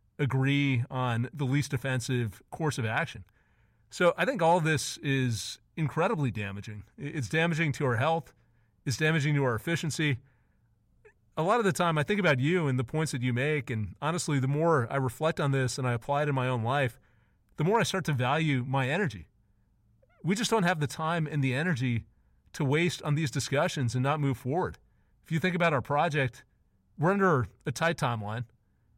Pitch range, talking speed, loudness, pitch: 120-155 Hz, 195 wpm, -29 LUFS, 135 Hz